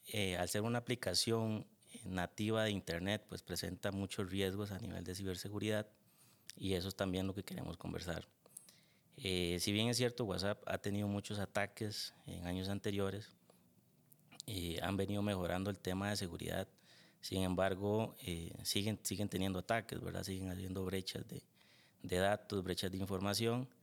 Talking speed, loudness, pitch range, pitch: 155 wpm, -40 LUFS, 95-105 Hz, 100 Hz